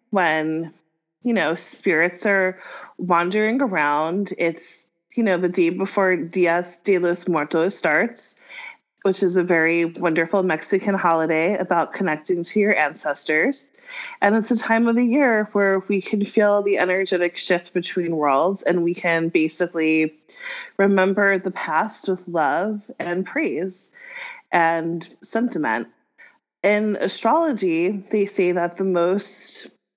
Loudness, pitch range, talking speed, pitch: -21 LUFS, 170-210 Hz, 130 wpm, 185 Hz